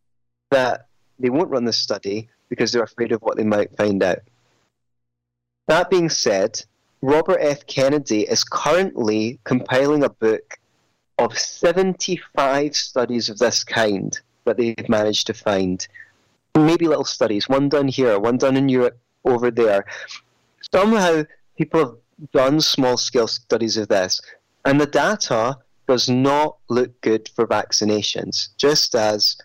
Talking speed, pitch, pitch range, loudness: 140 wpm, 125 Hz, 110-150 Hz, -19 LUFS